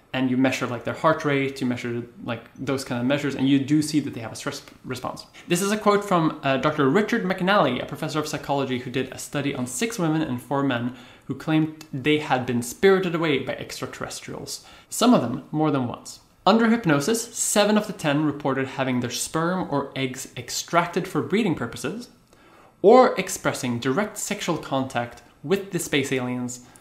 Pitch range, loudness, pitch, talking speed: 130-170 Hz, -24 LUFS, 145 Hz, 195 wpm